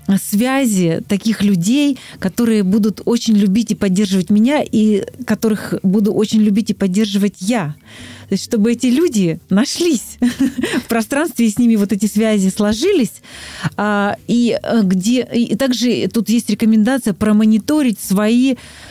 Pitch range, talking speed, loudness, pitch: 205-240 Hz, 125 wpm, -15 LUFS, 220 Hz